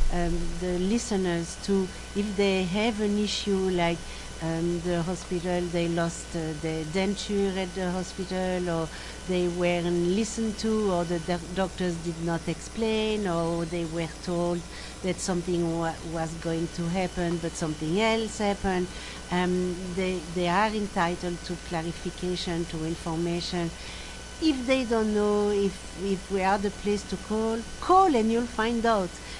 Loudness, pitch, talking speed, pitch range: -28 LUFS, 180 Hz, 150 wpm, 170-200 Hz